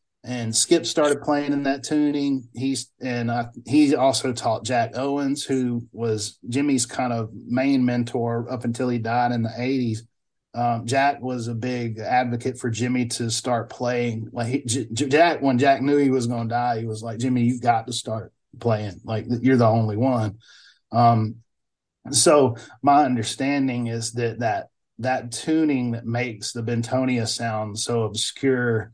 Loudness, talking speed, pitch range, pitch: -23 LUFS, 175 wpm, 115-130 Hz, 120 Hz